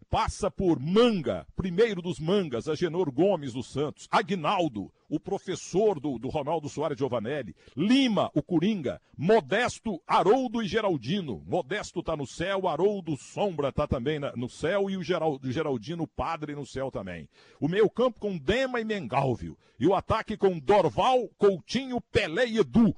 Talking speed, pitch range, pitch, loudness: 160 wpm, 150-205 Hz, 180 Hz, -28 LUFS